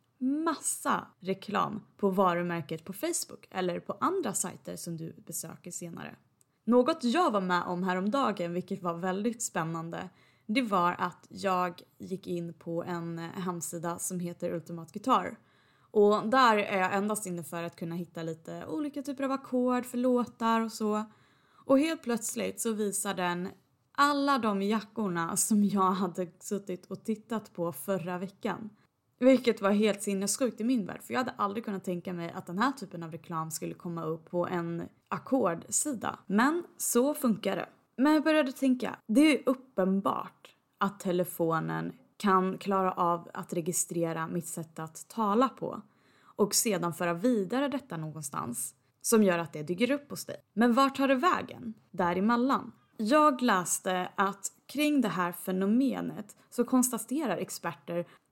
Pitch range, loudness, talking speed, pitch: 175-240 Hz, -30 LUFS, 155 wpm, 195 Hz